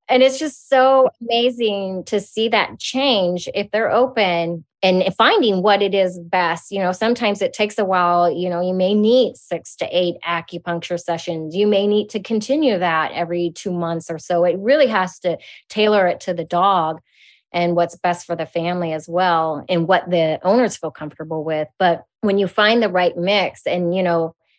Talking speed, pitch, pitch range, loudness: 195 wpm, 185 Hz, 170-210 Hz, -18 LUFS